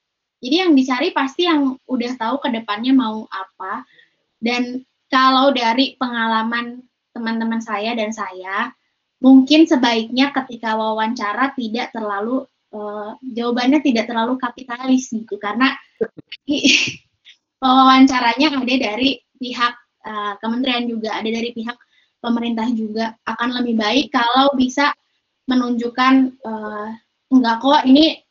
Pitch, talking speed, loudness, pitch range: 245 Hz, 115 wpm, -17 LUFS, 225-265 Hz